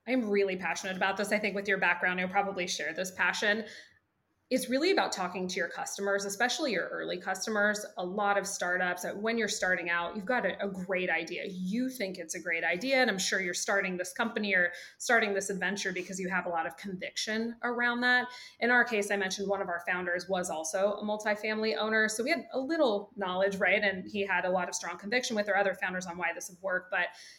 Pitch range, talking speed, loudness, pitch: 180-215 Hz, 230 wpm, -30 LUFS, 200 Hz